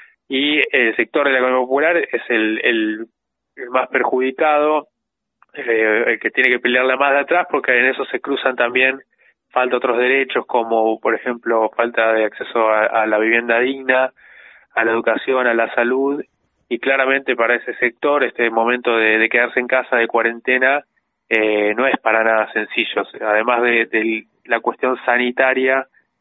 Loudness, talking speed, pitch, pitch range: -17 LUFS, 170 wpm, 120 Hz, 115-130 Hz